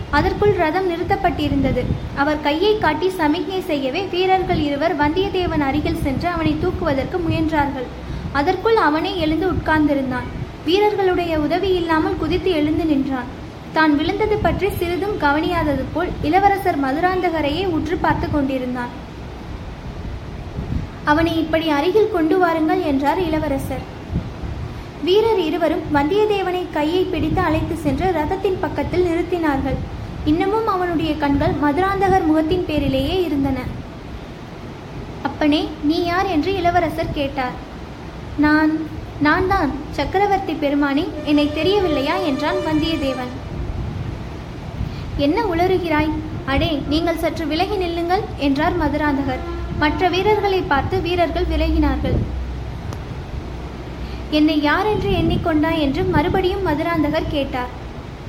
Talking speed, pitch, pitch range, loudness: 100 wpm, 320 Hz, 295-365 Hz, -19 LUFS